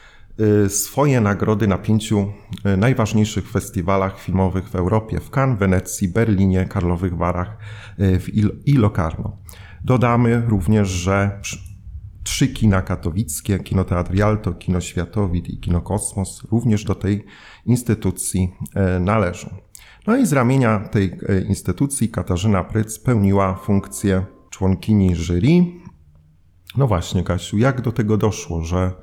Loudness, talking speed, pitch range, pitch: -19 LUFS, 115 wpm, 95-110 Hz, 100 Hz